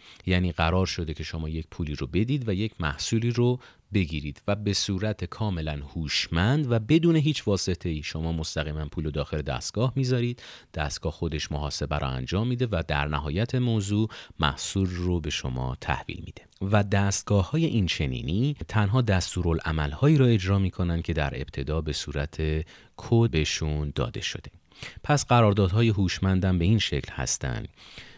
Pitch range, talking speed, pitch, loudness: 75-110 Hz, 155 wpm, 90 Hz, -26 LUFS